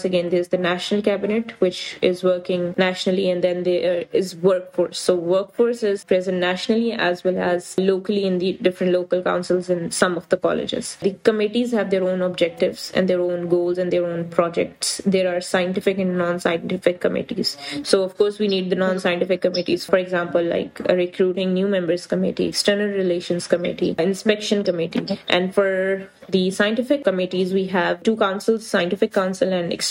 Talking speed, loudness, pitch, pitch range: 175 wpm, -21 LUFS, 185 Hz, 180-195 Hz